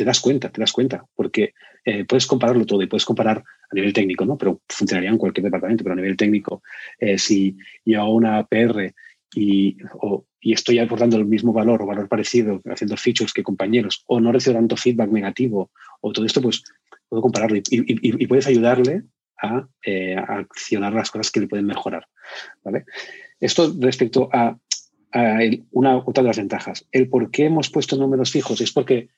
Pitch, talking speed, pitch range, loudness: 115 Hz, 195 wpm, 105-130 Hz, -20 LUFS